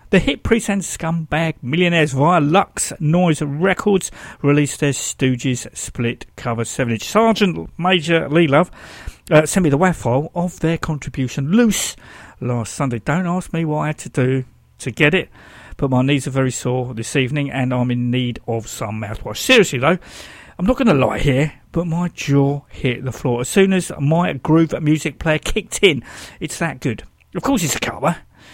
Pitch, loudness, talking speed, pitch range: 145 Hz, -18 LUFS, 190 wpm, 130-170 Hz